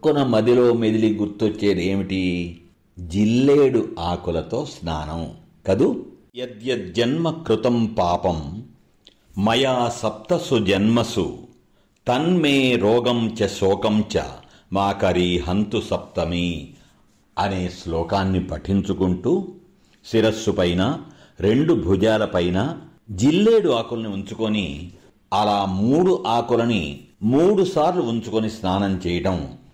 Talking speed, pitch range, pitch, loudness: 80 wpm, 95-120 Hz, 105 Hz, -21 LUFS